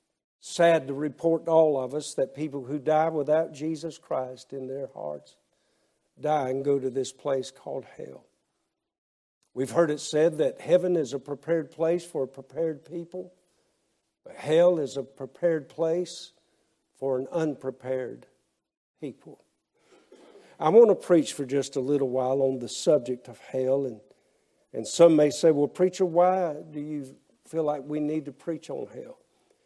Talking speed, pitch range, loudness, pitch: 165 wpm, 135-170 Hz, -26 LUFS, 150 Hz